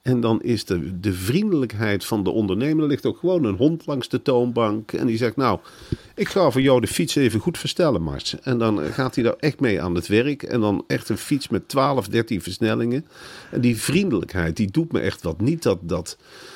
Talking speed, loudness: 225 wpm, -22 LUFS